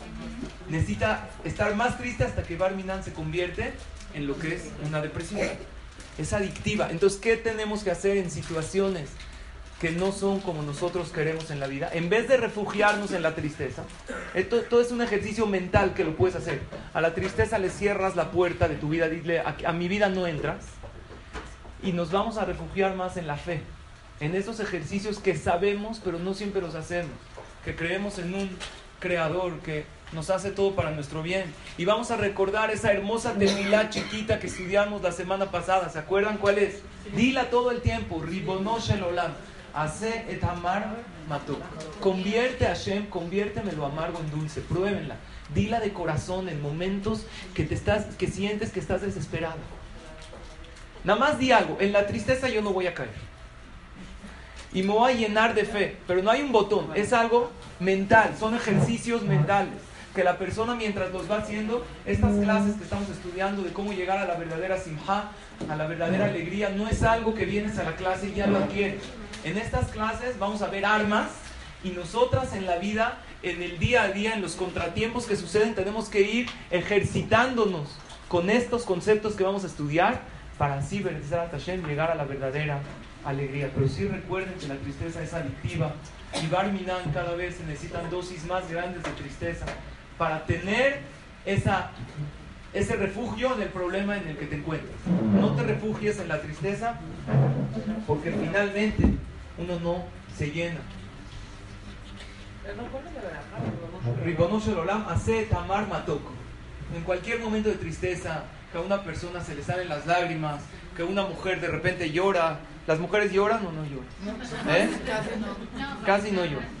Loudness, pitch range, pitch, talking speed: -27 LUFS, 160-205 Hz, 185 Hz, 170 wpm